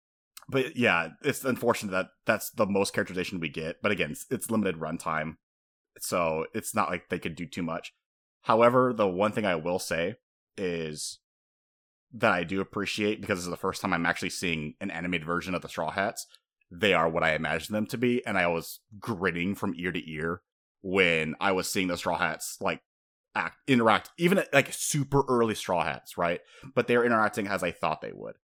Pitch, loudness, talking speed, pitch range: 95 Hz, -28 LUFS, 200 wpm, 85-110 Hz